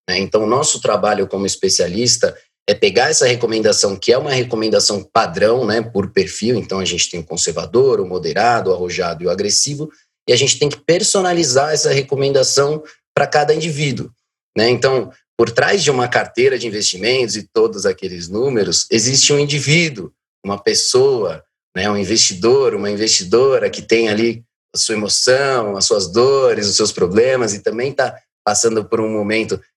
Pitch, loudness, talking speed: 150 Hz, -15 LUFS, 170 wpm